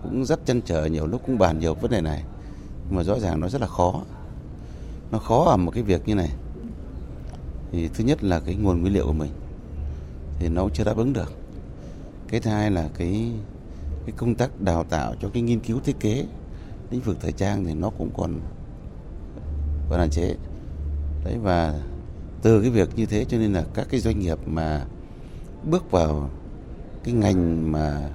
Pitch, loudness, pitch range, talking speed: 90 Hz, -25 LUFS, 75-105 Hz, 195 wpm